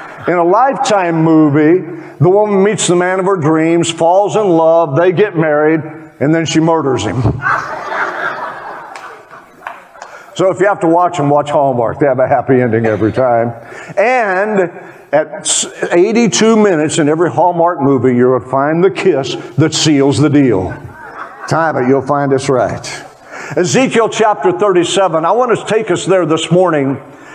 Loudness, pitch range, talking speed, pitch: -12 LUFS, 145-185 Hz, 160 wpm, 165 Hz